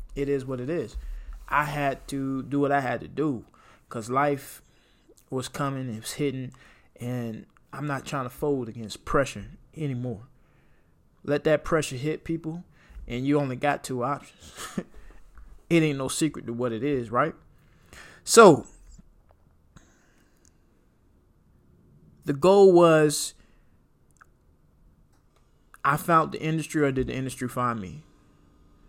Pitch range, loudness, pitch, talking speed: 120-145 Hz, -25 LUFS, 135 Hz, 135 wpm